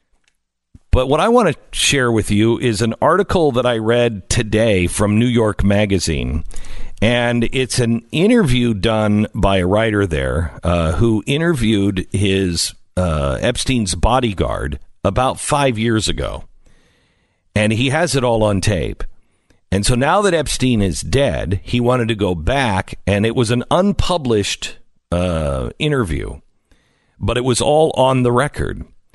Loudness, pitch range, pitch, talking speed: -17 LUFS, 90-125 Hz, 110 Hz, 150 wpm